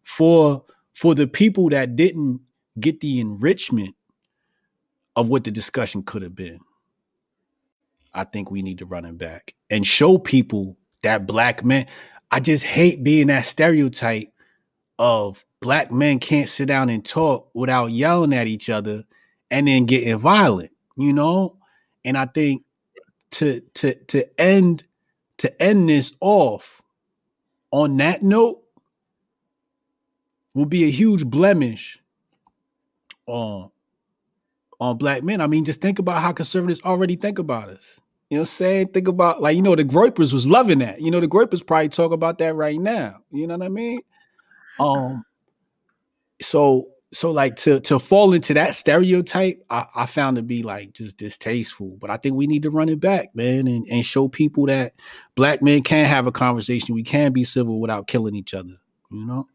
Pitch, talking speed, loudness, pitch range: 145 Hz, 170 wpm, -19 LUFS, 120-175 Hz